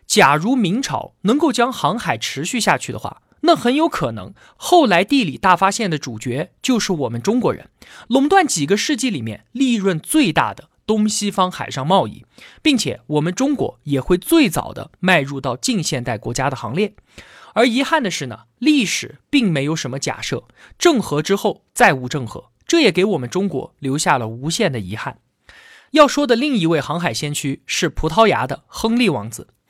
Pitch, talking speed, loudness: 190 Hz, 275 characters per minute, -18 LUFS